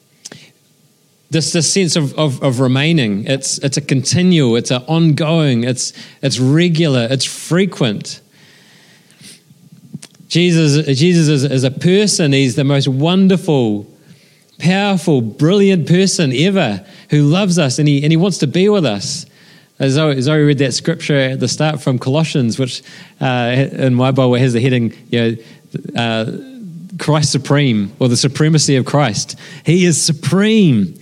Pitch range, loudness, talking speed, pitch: 135-170 Hz, -14 LUFS, 145 wpm, 150 Hz